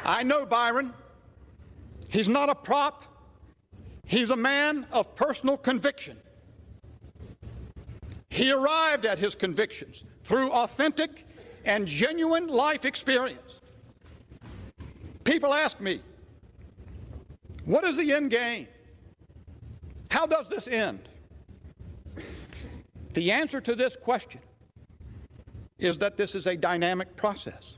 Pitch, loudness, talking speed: 235 Hz, -27 LUFS, 105 wpm